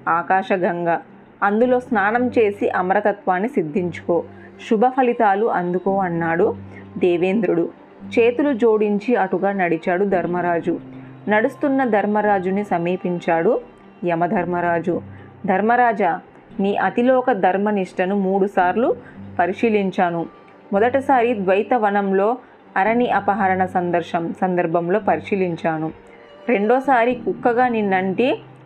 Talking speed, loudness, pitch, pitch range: 75 wpm, -19 LUFS, 195 Hz, 175-235 Hz